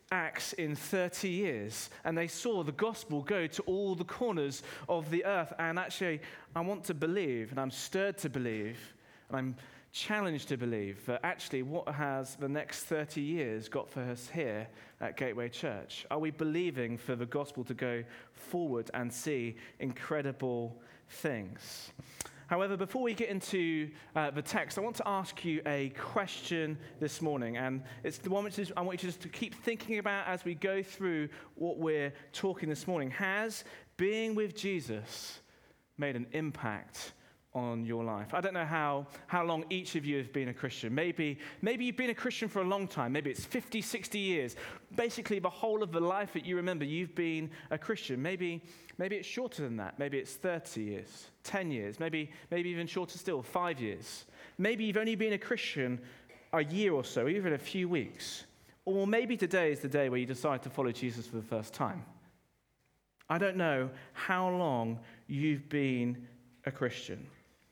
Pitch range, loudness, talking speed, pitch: 130-185 Hz, -36 LUFS, 185 wpm, 155 Hz